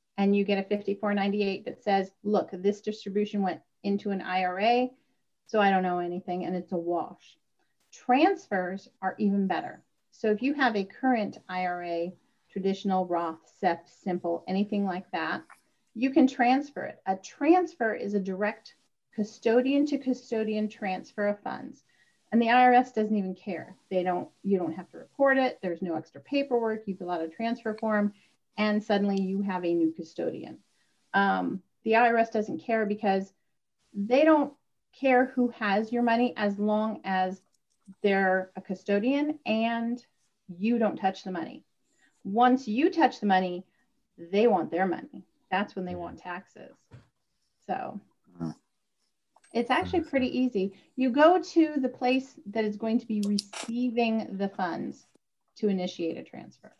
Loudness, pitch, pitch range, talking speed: -28 LUFS, 205 Hz, 190-240 Hz, 155 wpm